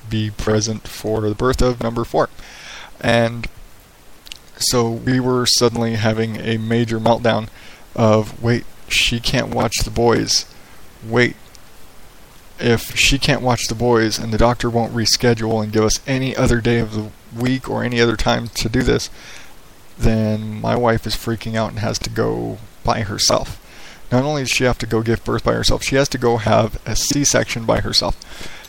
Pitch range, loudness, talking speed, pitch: 110-120 Hz, -18 LUFS, 175 wpm, 115 Hz